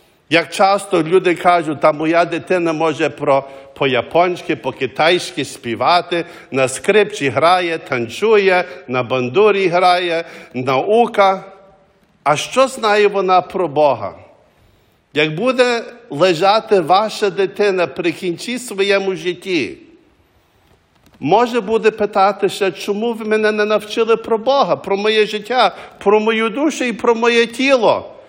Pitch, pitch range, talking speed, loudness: 190 Hz, 160-215 Hz, 115 wpm, -16 LUFS